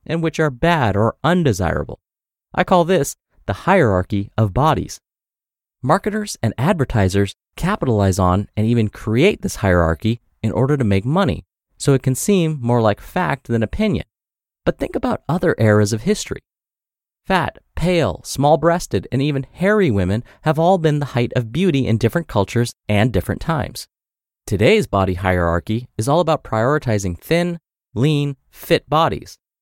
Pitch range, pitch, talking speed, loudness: 100-155 Hz, 120 Hz, 155 wpm, -18 LUFS